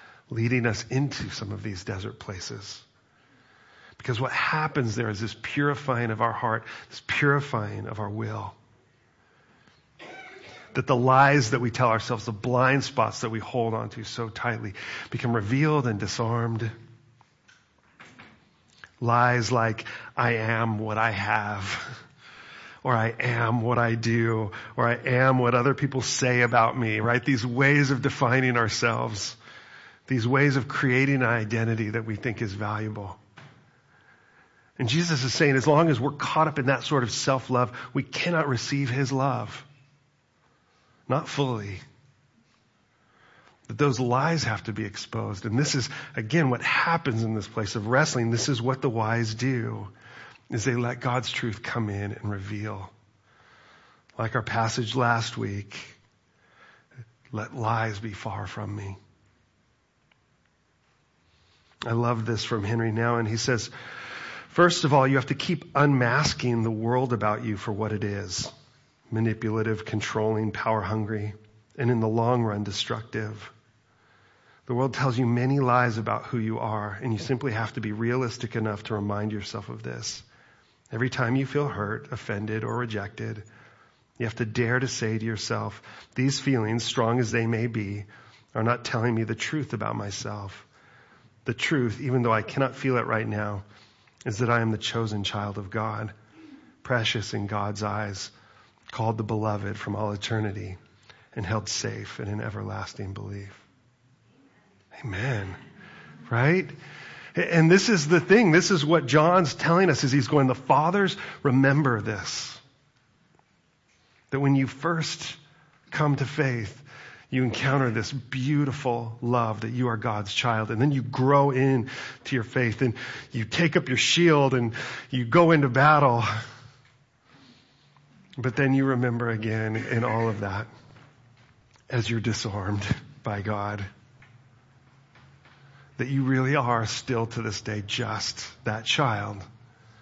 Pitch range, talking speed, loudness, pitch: 110-135 Hz, 150 wpm, -26 LUFS, 120 Hz